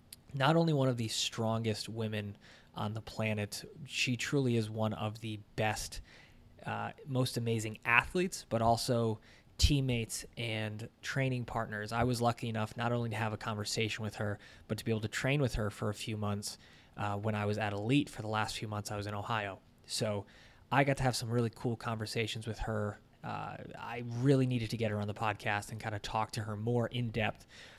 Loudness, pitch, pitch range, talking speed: -35 LUFS, 110 Hz, 105-120 Hz, 205 wpm